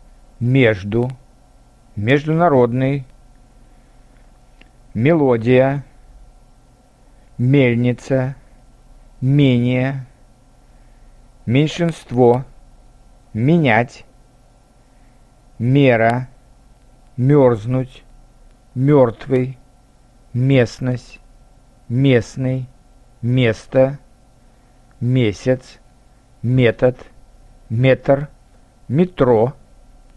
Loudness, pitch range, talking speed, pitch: -17 LUFS, 125-130 Hz, 35 wpm, 125 Hz